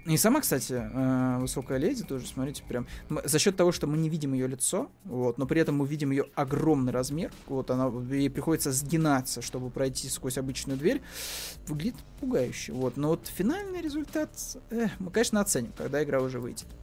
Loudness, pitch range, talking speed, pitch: -29 LUFS, 130-160 Hz, 180 wpm, 140 Hz